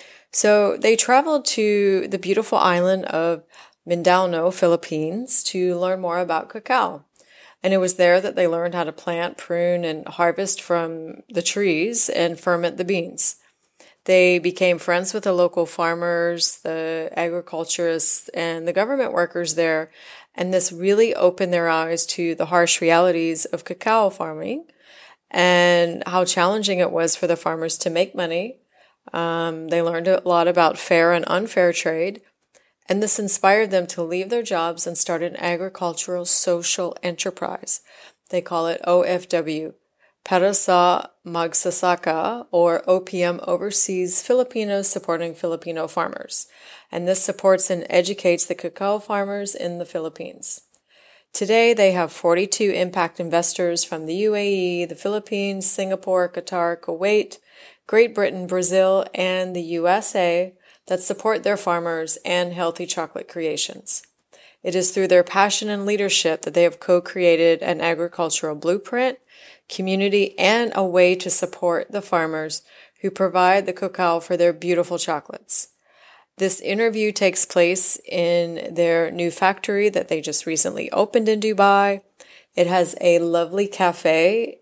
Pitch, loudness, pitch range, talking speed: 180 Hz, -19 LUFS, 170-195 Hz, 140 wpm